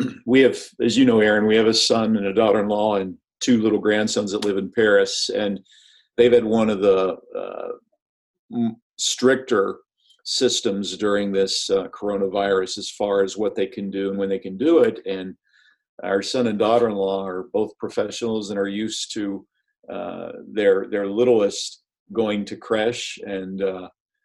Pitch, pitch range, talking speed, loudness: 105 Hz, 100-120 Hz, 180 wpm, -21 LUFS